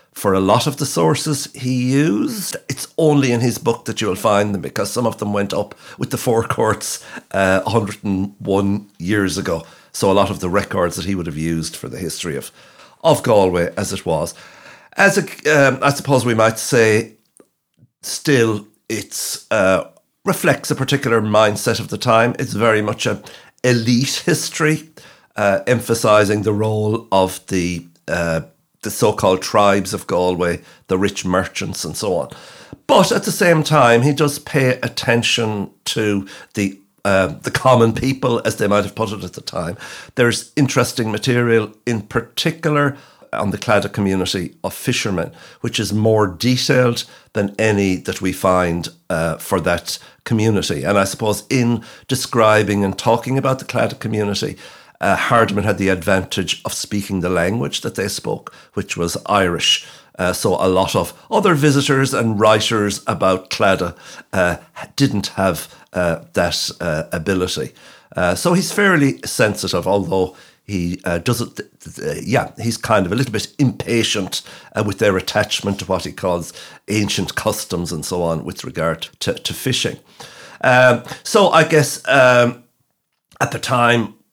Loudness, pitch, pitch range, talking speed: -18 LUFS, 110 Hz, 100-125 Hz, 165 wpm